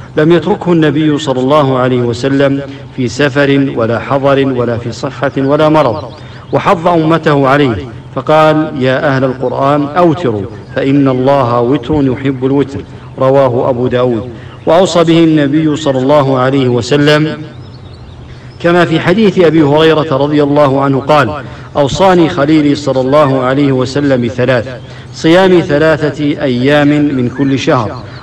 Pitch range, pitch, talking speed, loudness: 125-150 Hz, 140 Hz, 130 wpm, -10 LUFS